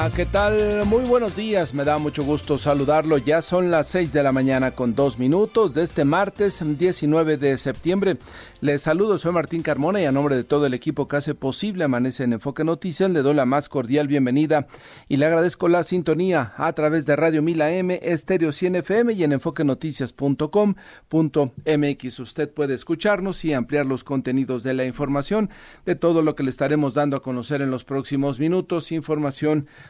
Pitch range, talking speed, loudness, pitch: 140-170 Hz, 185 wpm, -21 LUFS, 150 Hz